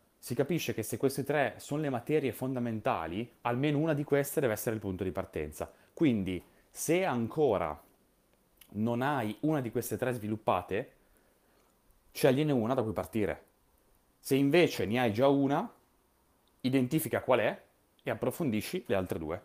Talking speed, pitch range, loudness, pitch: 150 wpm, 110-140 Hz, -31 LUFS, 125 Hz